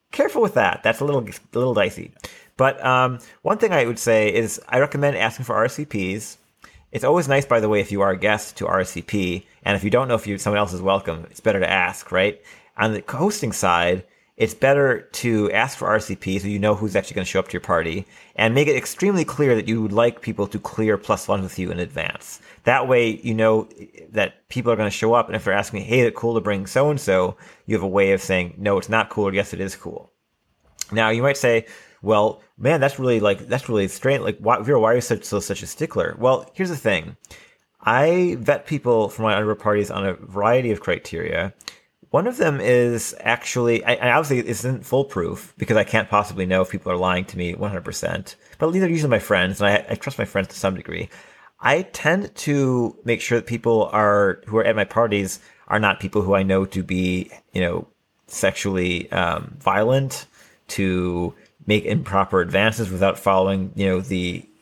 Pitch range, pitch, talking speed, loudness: 95-120 Hz, 105 Hz, 225 wpm, -21 LUFS